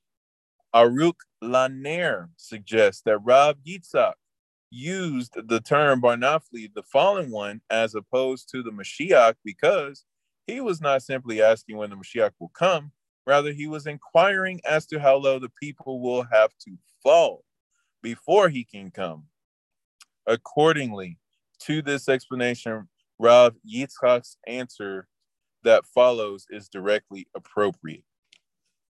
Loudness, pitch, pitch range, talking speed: -22 LUFS, 125 Hz, 110-145 Hz, 120 wpm